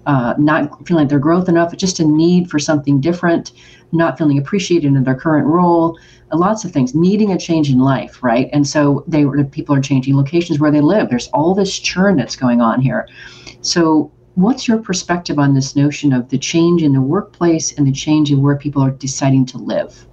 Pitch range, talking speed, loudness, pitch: 140-170 Hz, 210 wpm, -15 LUFS, 150 Hz